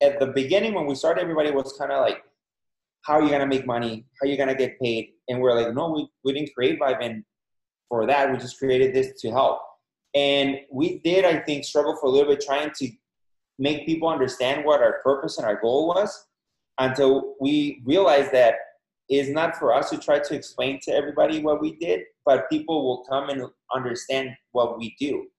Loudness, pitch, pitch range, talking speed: -23 LUFS, 140 Hz, 130-150 Hz, 210 wpm